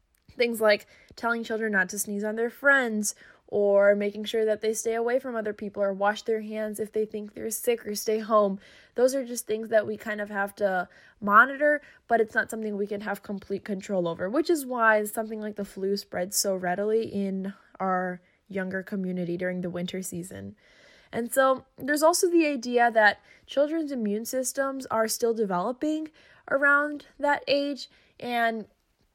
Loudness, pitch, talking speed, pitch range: -26 LUFS, 215 Hz, 180 wpm, 200-245 Hz